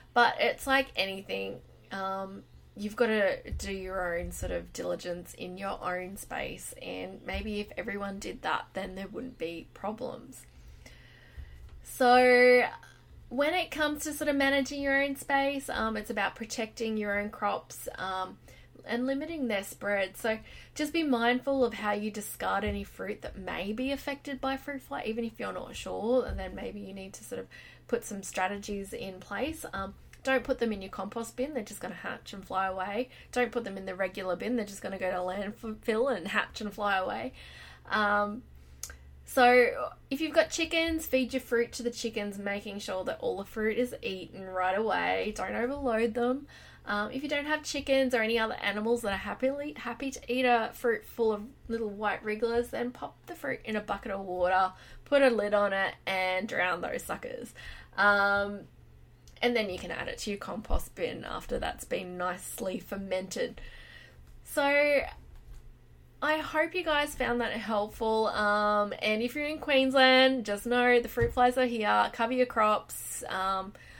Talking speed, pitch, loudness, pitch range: 185 wpm, 220 Hz, -30 LUFS, 195-255 Hz